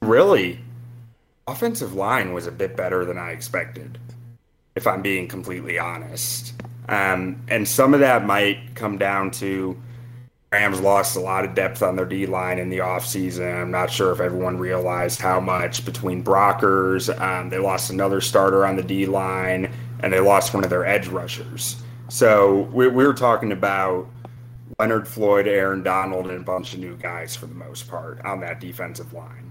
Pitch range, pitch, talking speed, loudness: 95-120 Hz, 100 Hz, 175 wpm, -21 LUFS